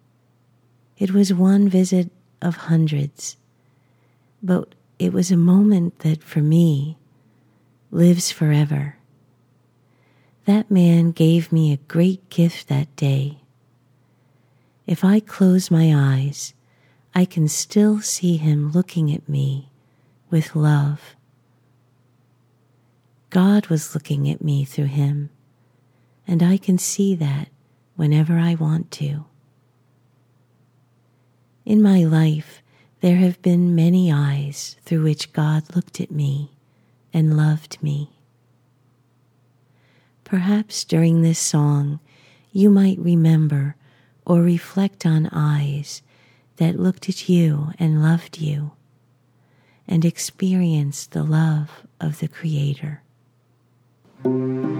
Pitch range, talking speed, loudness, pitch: 130-170 Hz, 105 wpm, -19 LUFS, 150 Hz